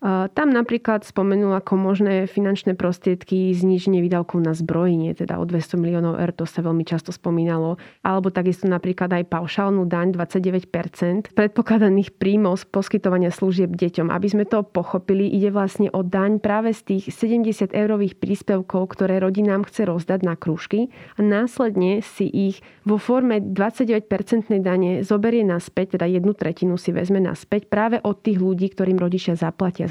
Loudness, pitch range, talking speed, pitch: -21 LUFS, 180-205 Hz, 155 wpm, 190 Hz